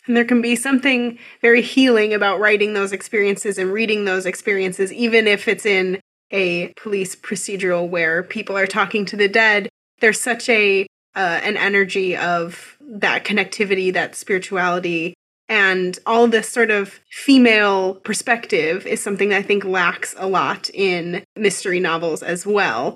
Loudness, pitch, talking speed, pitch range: -18 LUFS, 200 Hz, 155 wpm, 185-225 Hz